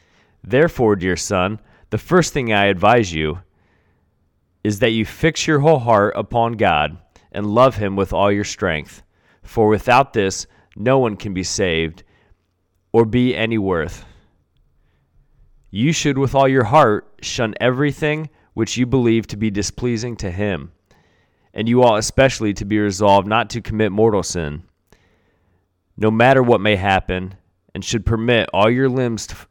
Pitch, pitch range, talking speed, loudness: 105 Hz, 95-120 Hz, 155 wpm, -17 LUFS